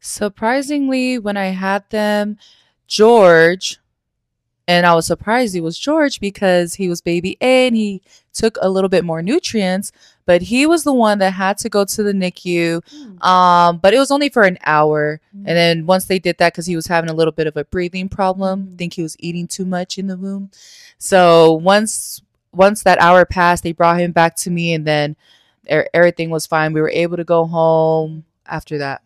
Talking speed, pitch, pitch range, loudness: 200 wpm, 180 Hz, 170-200 Hz, -15 LUFS